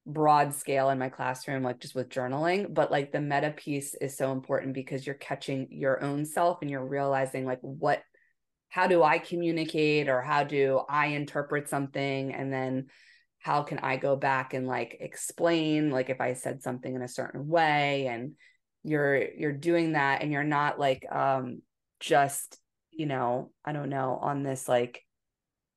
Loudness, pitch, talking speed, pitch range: -29 LUFS, 140 Hz, 175 wpm, 130-150 Hz